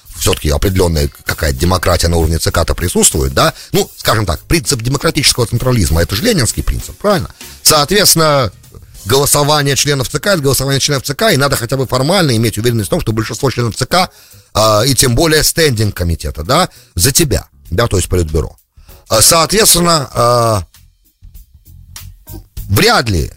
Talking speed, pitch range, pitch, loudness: 150 wpm, 90-140 Hz, 110 Hz, -12 LUFS